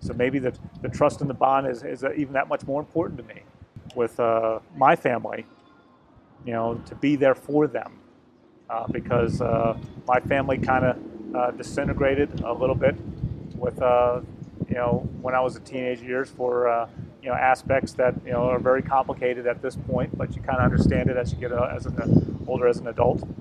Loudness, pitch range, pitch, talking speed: -24 LUFS, 120-135 Hz, 125 Hz, 210 wpm